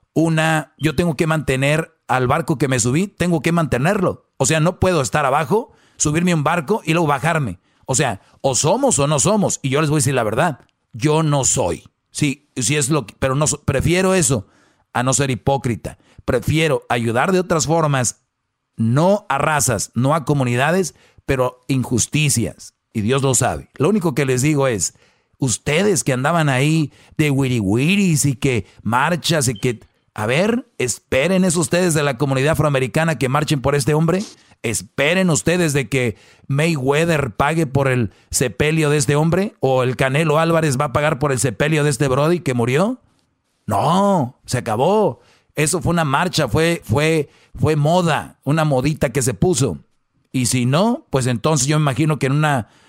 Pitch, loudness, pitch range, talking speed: 145 Hz, -18 LUFS, 130-165 Hz, 180 wpm